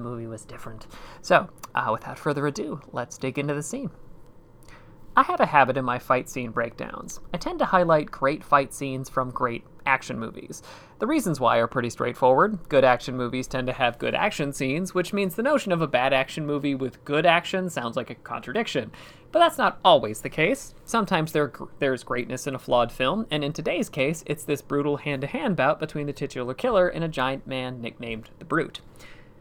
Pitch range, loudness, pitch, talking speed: 125-155 Hz, -25 LUFS, 140 Hz, 205 wpm